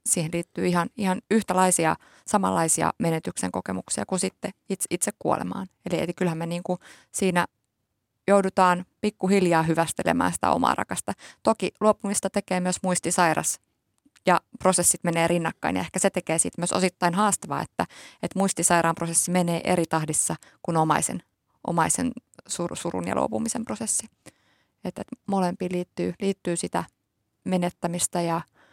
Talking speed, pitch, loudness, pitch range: 135 wpm, 175 Hz, -25 LUFS, 165-190 Hz